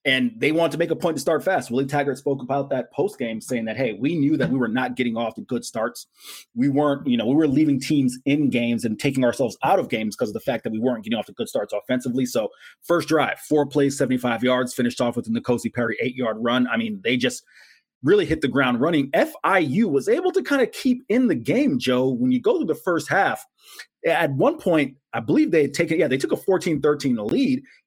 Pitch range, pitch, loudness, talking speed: 125-175 Hz, 140 Hz, -22 LUFS, 255 wpm